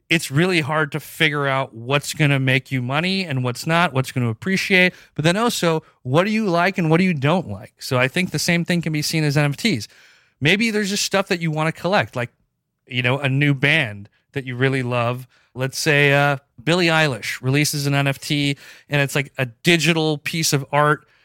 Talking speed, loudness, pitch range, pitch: 220 wpm, -19 LUFS, 135-170 Hz, 150 Hz